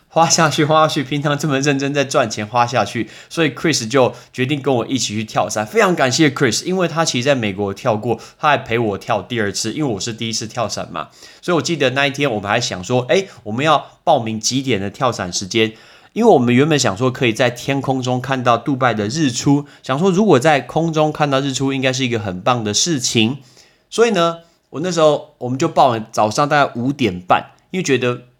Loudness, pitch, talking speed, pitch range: -17 LUFS, 130 Hz, 345 characters per minute, 115-150 Hz